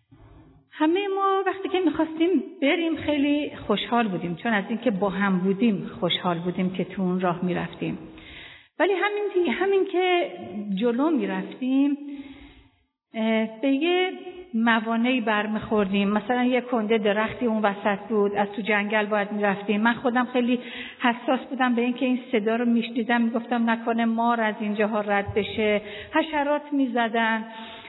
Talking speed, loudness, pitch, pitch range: 140 wpm, -24 LUFS, 230 Hz, 210-280 Hz